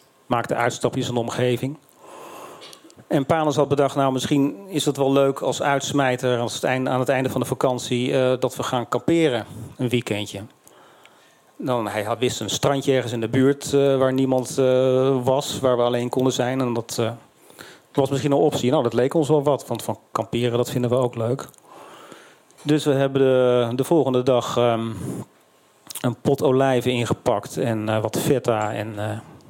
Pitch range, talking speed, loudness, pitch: 120-140 Hz, 185 wpm, -22 LUFS, 130 Hz